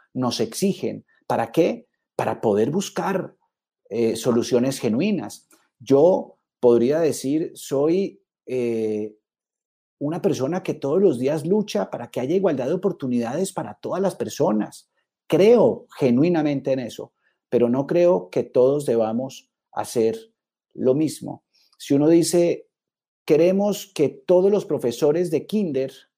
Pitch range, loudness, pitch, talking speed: 130-195 Hz, -22 LUFS, 165 Hz, 125 wpm